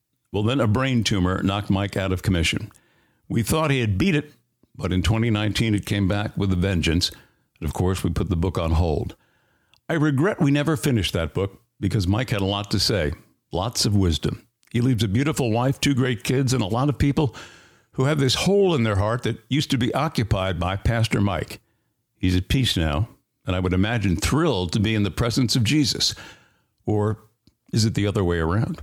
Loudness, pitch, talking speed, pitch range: -22 LUFS, 110 Hz, 210 wpm, 95-130 Hz